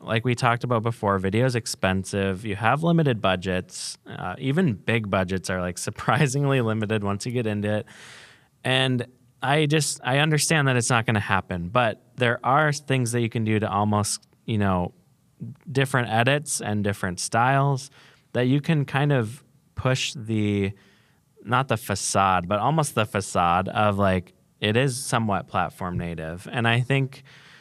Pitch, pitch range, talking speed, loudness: 115 Hz, 100-135 Hz, 165 wpm, -24 LUFS